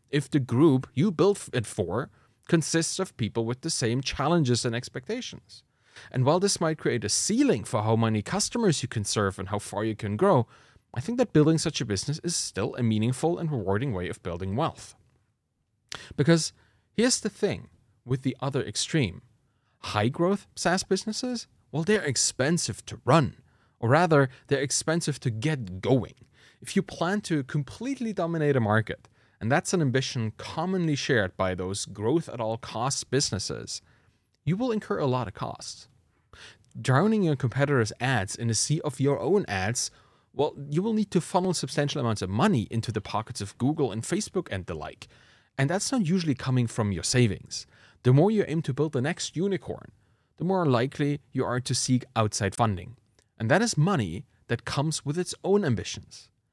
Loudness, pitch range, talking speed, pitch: -27 LUFS, 110-165 Hz, 180 wpm, 130 Hz